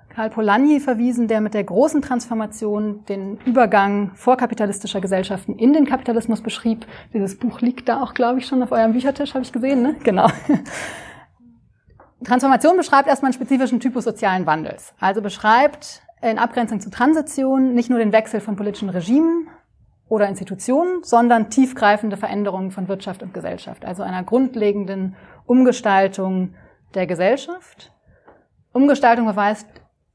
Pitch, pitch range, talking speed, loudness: 225 Hz, 205-255 Hz, 140 wpm, -19 LUFS